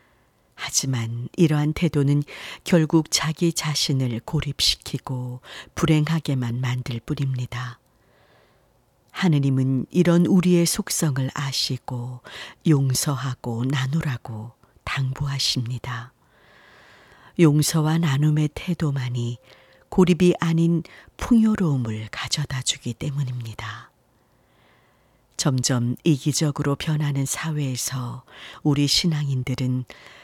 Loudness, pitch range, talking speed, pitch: -23 LUFS, 125-155 Hz, 220 characters per minute, 140 Hz